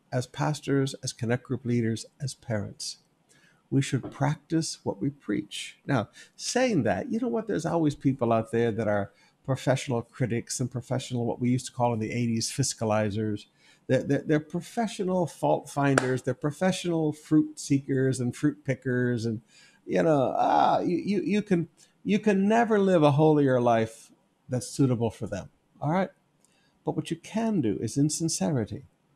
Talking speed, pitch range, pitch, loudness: 170 wpm, 120-165 Hz, 140 Hz, -27 LUFS